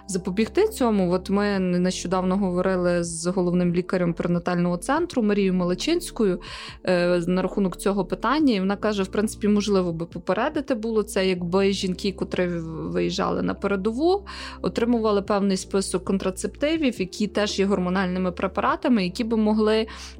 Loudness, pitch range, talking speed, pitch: -24 LUFS, 180-215 Hz, 135 wpm, 195 Hz